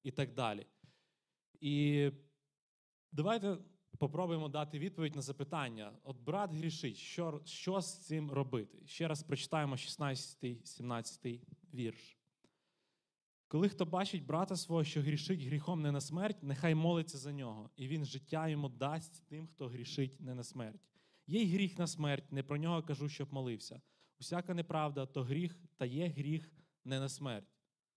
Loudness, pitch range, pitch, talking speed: -40 LUFS, 135-165 Hz, 150 Hz, 150 wpm